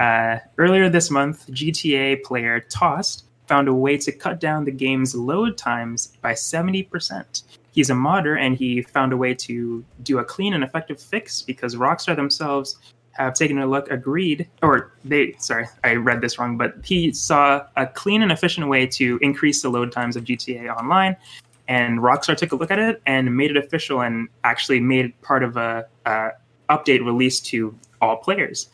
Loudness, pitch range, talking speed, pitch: -20 LUFS, 120-150 Hz, 185 wpm, 130 Hz